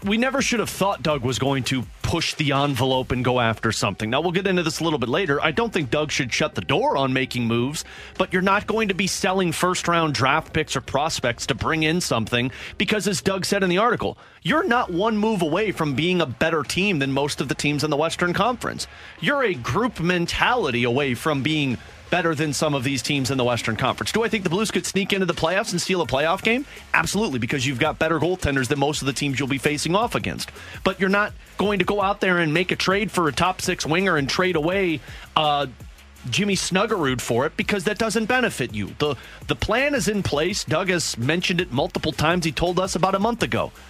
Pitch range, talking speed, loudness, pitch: 135-190 Hz, 240 wpm, -22 LUFS, 160 Hz